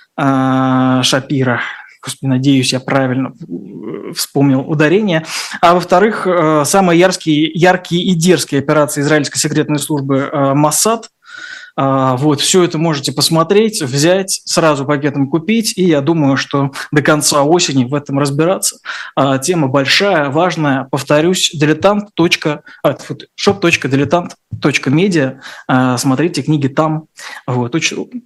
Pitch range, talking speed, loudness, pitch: 140-175 Hz, 100 wpm, -13 LUFS, 150 Hz